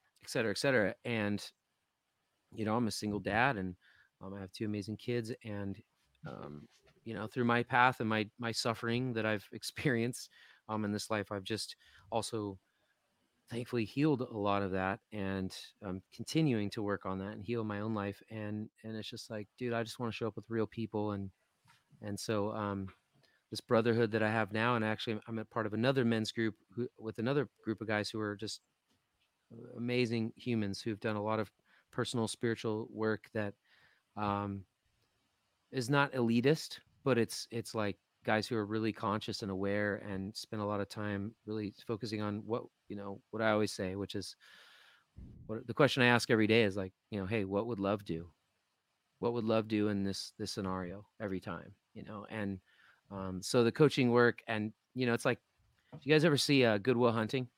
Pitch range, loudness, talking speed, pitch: 100-115 Hz, -35 LUFS, 200 wpm, 110 Hz